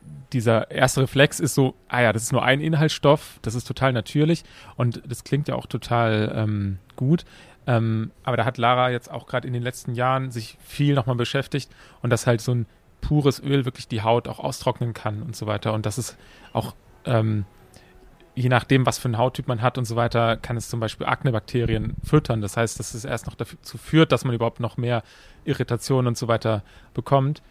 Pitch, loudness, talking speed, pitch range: 125 Hz, -23 LUFS, 210 wpm, 115-135 Hz